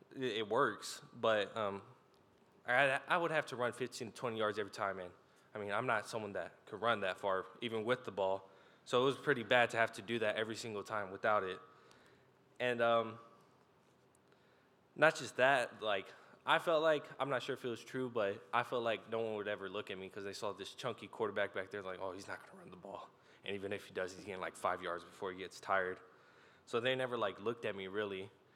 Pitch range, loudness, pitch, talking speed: 100-125 Hz, -38 LUFS, 115 Hz, 235 wpm